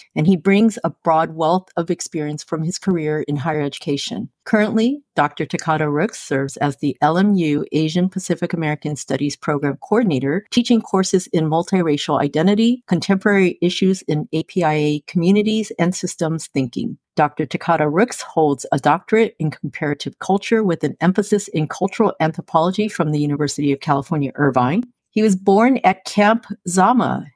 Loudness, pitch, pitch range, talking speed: -19 LUFS, 170 Hz, 150-195 Hz, 150 wpm